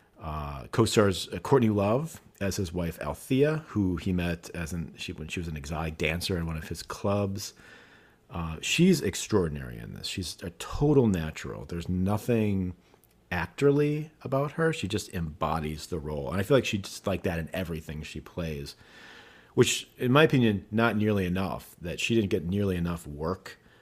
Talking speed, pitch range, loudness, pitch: 175 wpm, 80-110 Hz, -29 LUFS, 95 Hz